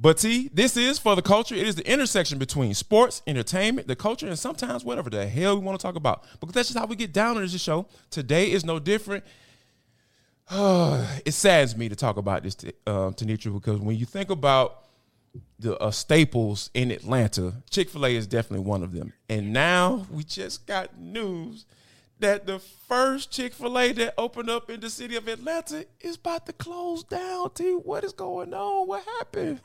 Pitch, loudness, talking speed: 180 Hz, -25 LUFS, 195 wpm